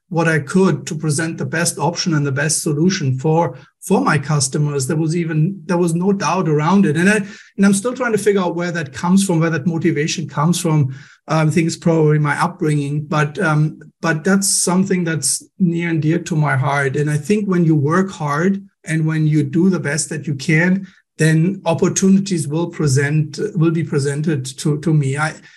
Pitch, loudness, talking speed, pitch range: 165 Hz, -17 LUFS, 210 wpm, 150-180 Hz